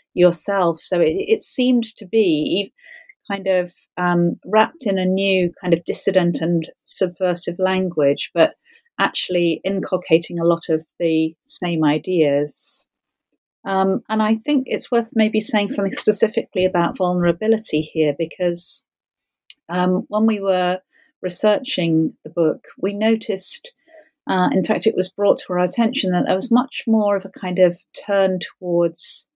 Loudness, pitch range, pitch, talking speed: -19 LUFS, 175-220 Hz, 190 Hz, 145 wpm